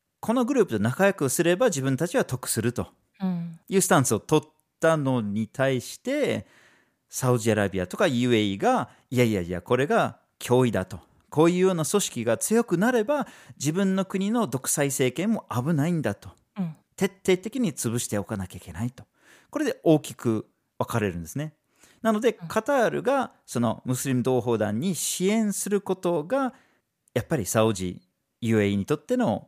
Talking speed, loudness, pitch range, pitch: 335 characters per minute, -25 LUFS, 115-195 Hz, 145 Hz